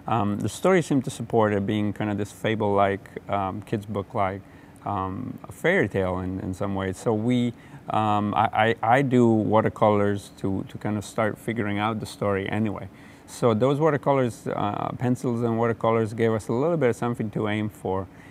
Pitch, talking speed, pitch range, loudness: 110 Hz, 190 wpm, 100-120 Hz, -25 LUFS